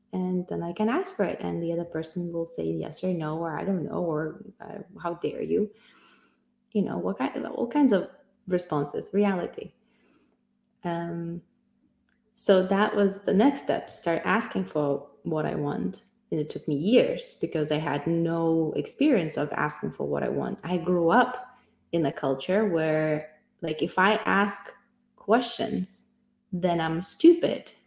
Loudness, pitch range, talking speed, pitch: -27 LUFS, 165-215 Hz, 170 wpm, 185 Hz